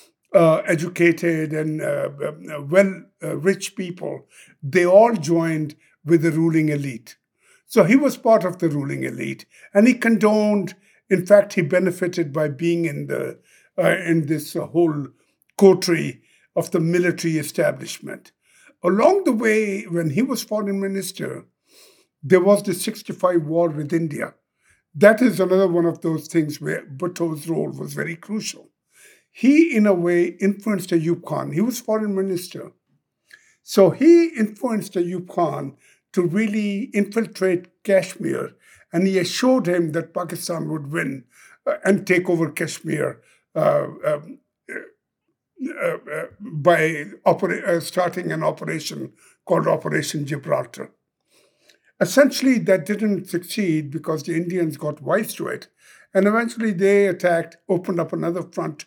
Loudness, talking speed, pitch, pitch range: -20 LUFS, 140 wpm, 180 Hz, 165-205 Hz